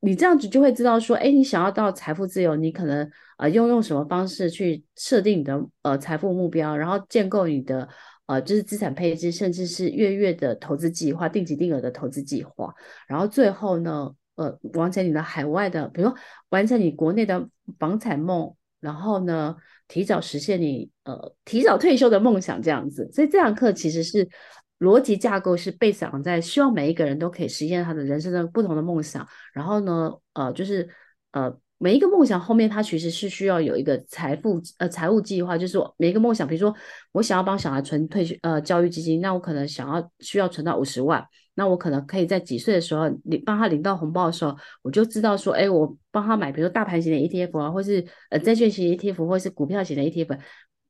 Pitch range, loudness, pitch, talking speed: 155-205 Hz, -23 LUFS, 175 Hz, 330 characters per minute